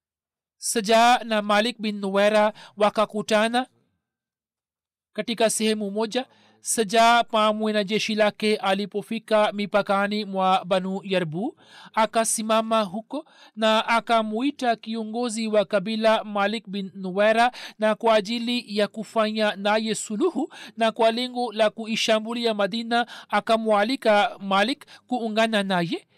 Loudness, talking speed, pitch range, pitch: -23 LUFS, 100 wpm, 210-230 Hz, 220 Hz